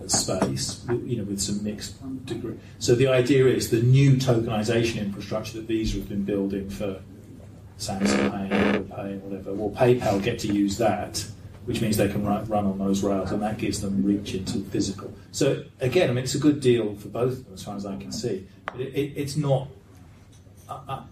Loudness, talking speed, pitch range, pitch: -25 LUFS, 195 wpm, 100-120 Hz, 105 Hz